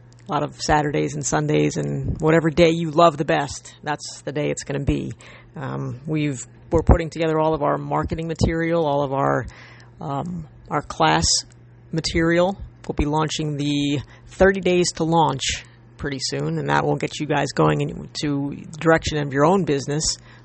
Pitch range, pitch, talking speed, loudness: 120-160 Hz, 145 Hz, 180 wpm, -21 LUFS